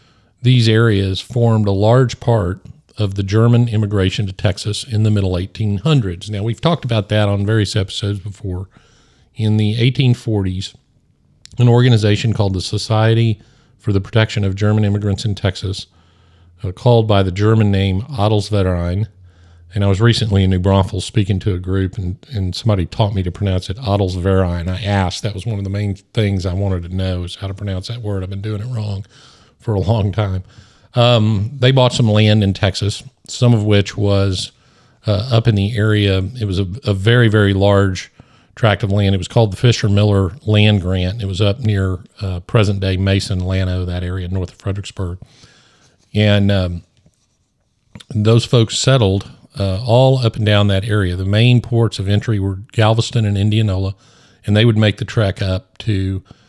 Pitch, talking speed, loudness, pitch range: 105 Hz, 185 wpm, -16 LUFS, 95-115 Hz